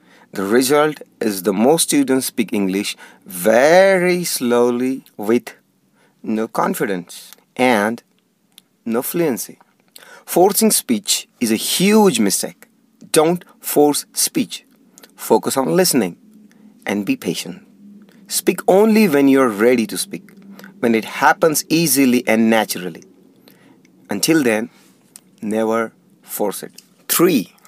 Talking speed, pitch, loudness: 110 wpm, 150 Hz, -16 LUFS